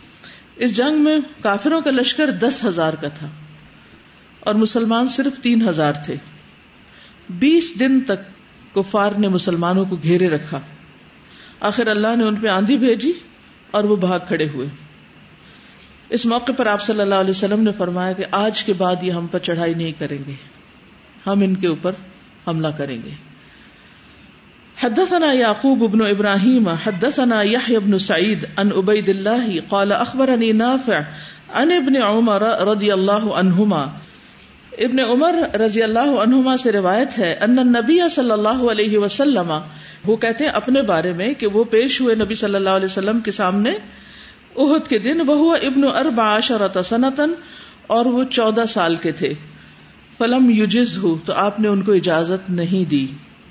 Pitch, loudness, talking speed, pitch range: 215 Hz, -17 LUFS, 150 wpm, 185-245 Hz